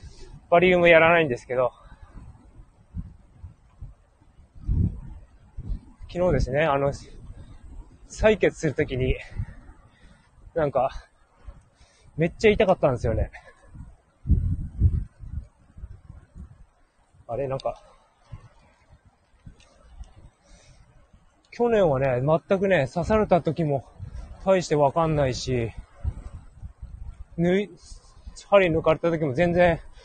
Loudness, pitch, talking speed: -23 LUFS, 135 Hz, 160 characters per minute